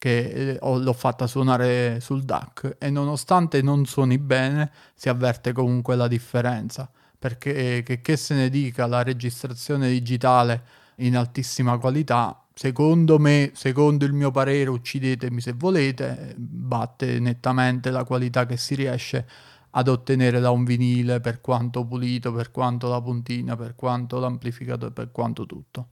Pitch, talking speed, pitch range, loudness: 125 Hz, 145 wpm, 125-135 Hz, -23 LUFS